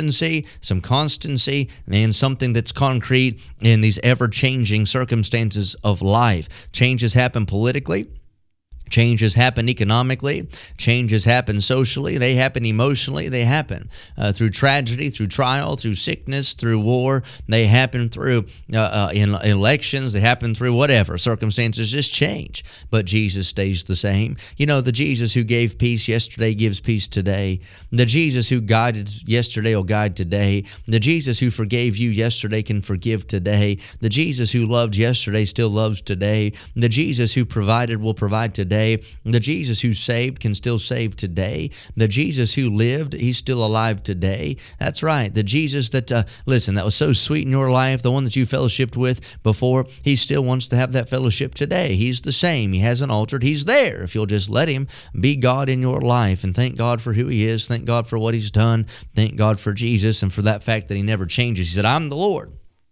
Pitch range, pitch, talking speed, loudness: 105-130 Hz, 115 Hz, 185 wpm, -19 LUFS